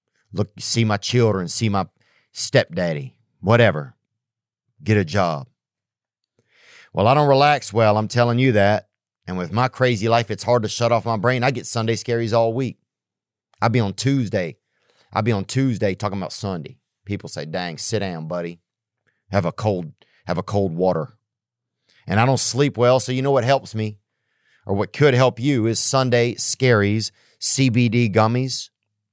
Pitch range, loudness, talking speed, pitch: 105-125 Hz, -20 LUFS, 170 wpm, 115 Hz